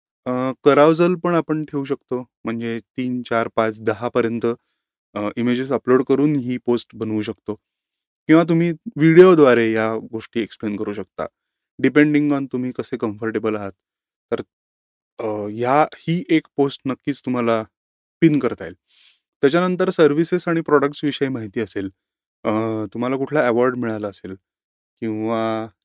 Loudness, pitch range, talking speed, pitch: -19 LUFS, 110-145 Hz, 130 wpm, 120 Hz